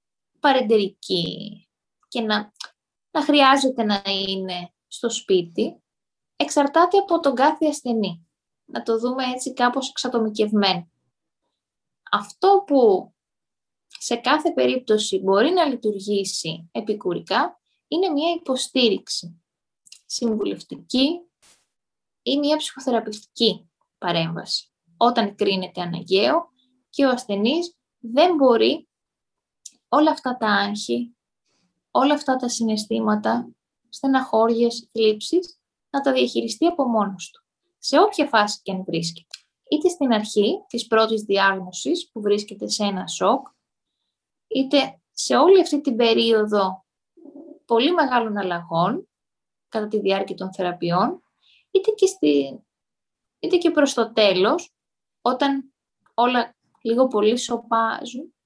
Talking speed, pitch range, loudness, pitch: 105 wpm, 200-280 Hz, -21 LUFS, 230 Hz